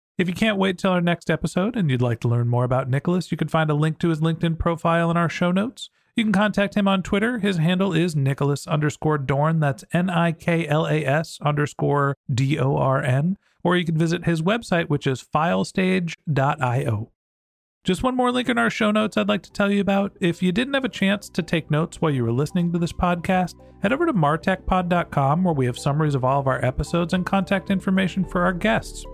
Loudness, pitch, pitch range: -22 LUFS, 170 Hz, 145-190 Hz